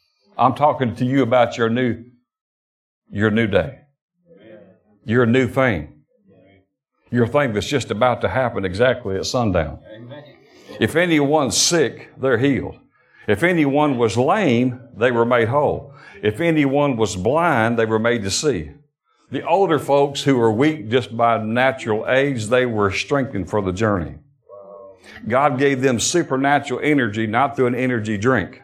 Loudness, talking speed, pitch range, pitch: -19 LUFS, 150 wpm, 110-140 Hz, 120 Hz